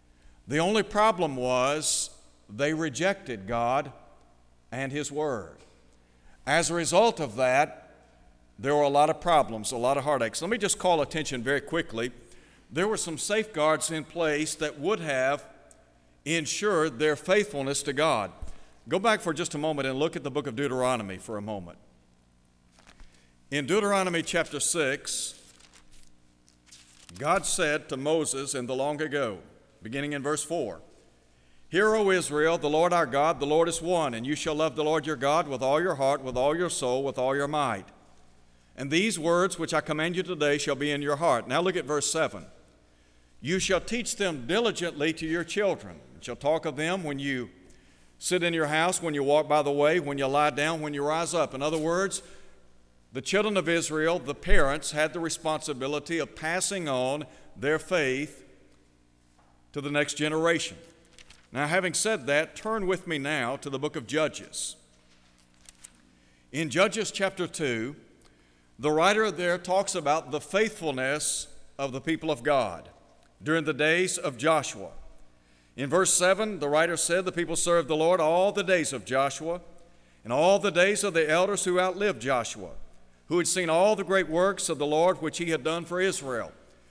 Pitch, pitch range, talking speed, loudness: 150 Hz, 125-170 Hz, 175 wpm, -27 LUFS